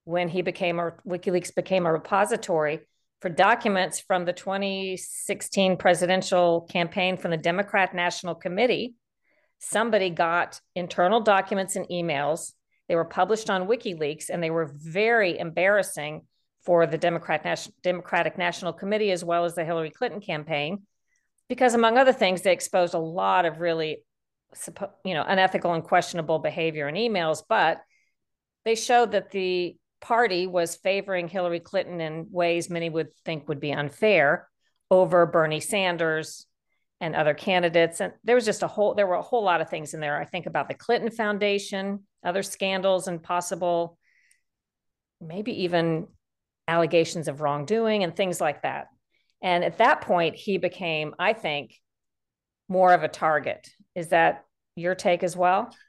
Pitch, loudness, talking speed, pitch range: 180 Hz, -25 LUFS, 155 wpm, 165-195 Hz